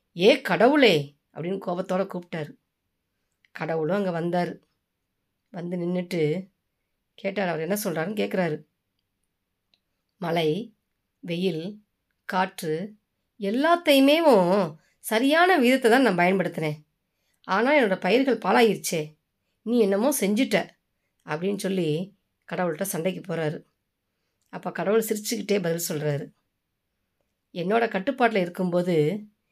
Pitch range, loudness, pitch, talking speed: 155-210 Hz, -24 LUFS, 180 Hz, 90 wpm